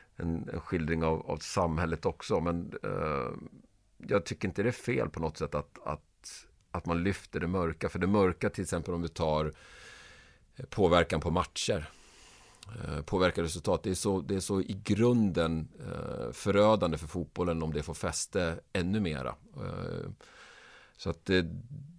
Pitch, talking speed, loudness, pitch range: 90 Hz, 165 wpm, -32 LUFS, 80-100 Hz